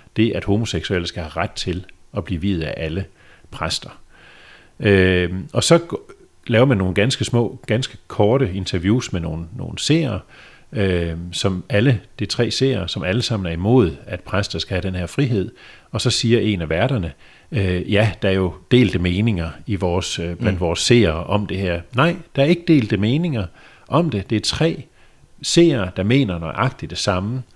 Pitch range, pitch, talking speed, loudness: 90-120 Hz, 100 Hz, 185 wpm, -19 LUFS